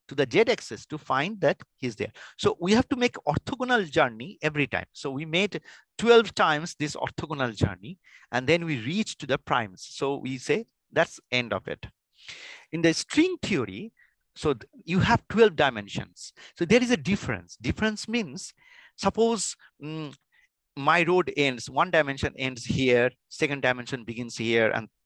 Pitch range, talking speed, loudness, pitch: 125-200 Hz, 170 wpm, -26 LUFS, 155 Hz